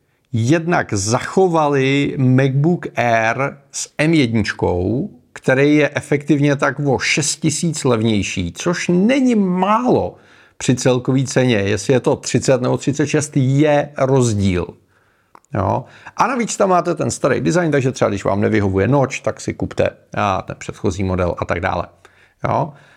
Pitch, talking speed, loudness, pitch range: 135 Hz, 135 wpm, -17 LUFS, 115-150 Hz